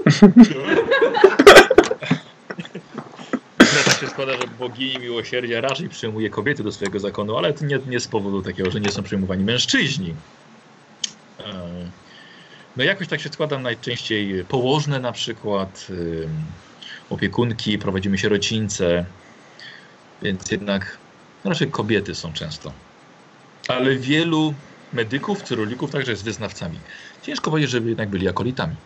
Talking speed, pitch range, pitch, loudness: 120 wpm, 100-145 Hz, 120 Hz, -19 LUFS